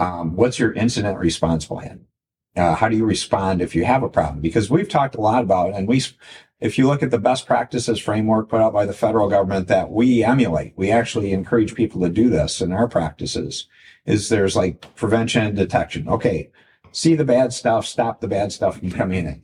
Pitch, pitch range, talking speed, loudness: 110 Hz, 95-120 Hz, 215 wpm, -19 LUFS